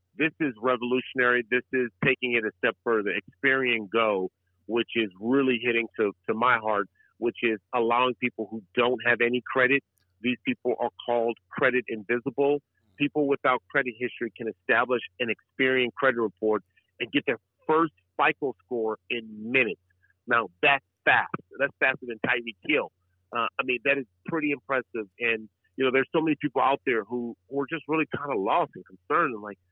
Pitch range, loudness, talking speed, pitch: 110-130 Hz, -26 LUFS, 180 wpm, 120 Hz